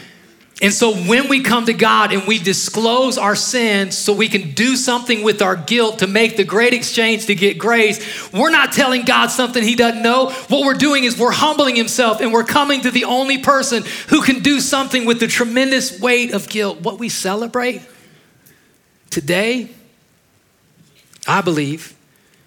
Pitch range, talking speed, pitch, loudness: 205-250 Hz, 175 wpm, 230 Hz, -15 LUFS